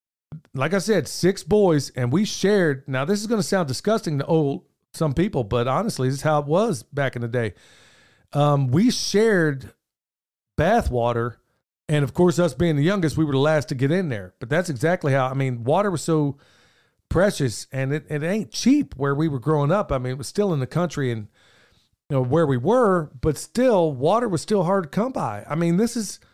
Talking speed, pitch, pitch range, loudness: 220 wpm, 155 Hz, 135-185 Hz, -22 LUFS